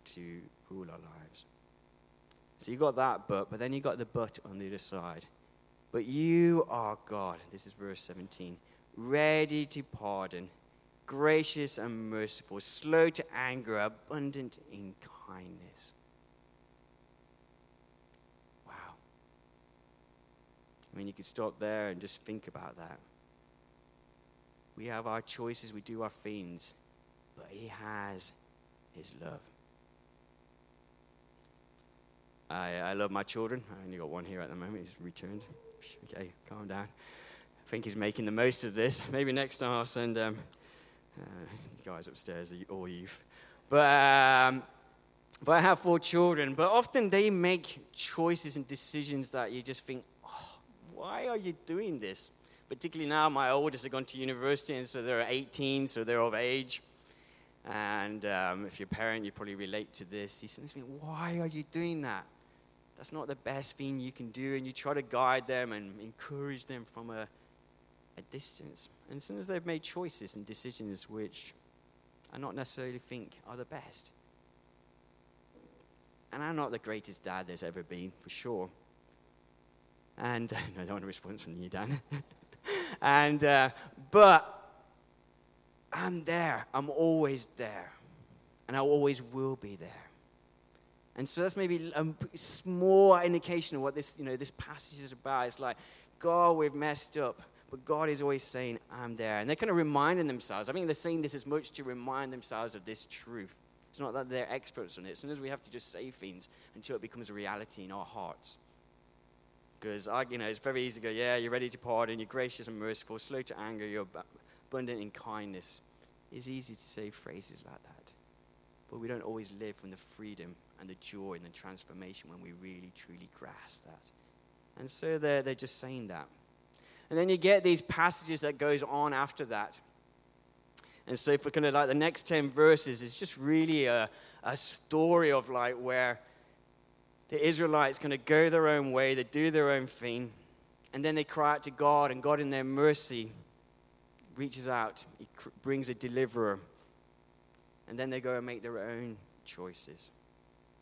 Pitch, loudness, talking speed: 110 Hz, -33 LUFS, 170 wpm